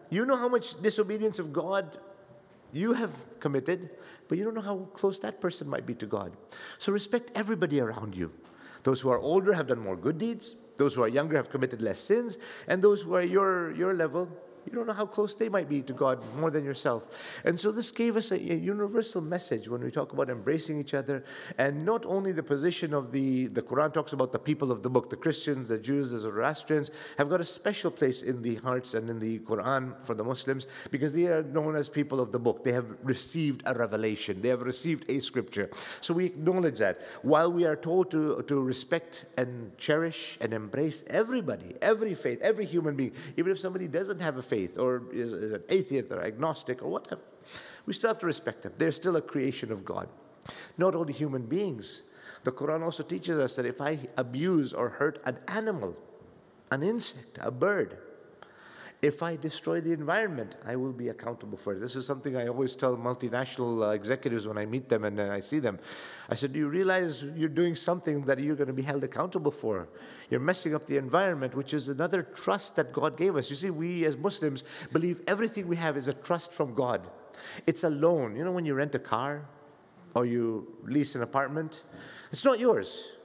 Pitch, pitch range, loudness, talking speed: 150 Hz, 130-180 Hz, -30 LUFS, 210 wpm